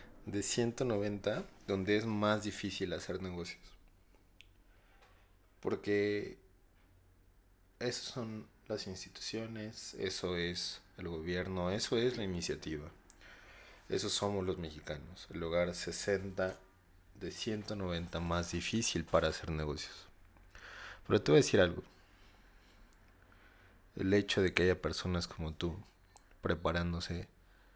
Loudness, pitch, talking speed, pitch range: -36 LUFS, 95 Hz, 110 wpm, 90-105 Hz